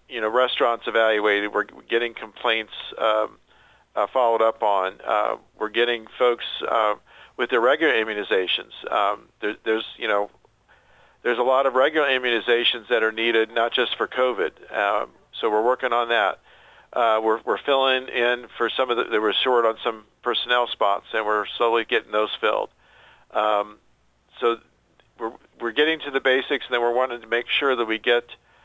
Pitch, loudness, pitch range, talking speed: 115 Hz, -22 LUFS, 110-120 Hz, 180 wpm